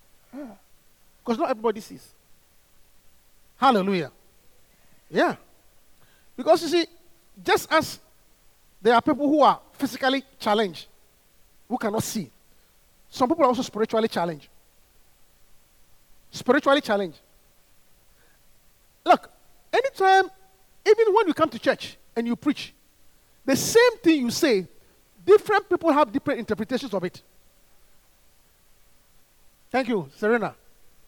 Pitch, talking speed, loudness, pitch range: 270 Hz, 105 wpm, -23 LUFS, 230-335 Hz